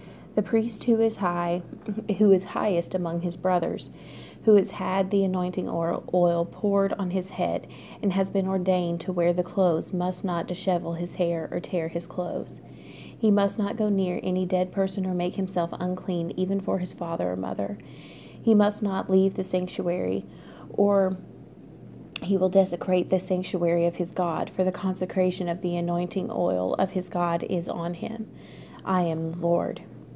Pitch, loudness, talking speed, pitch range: 185 Hz, -26 LUFS, 175 wpm, 175-195 Hz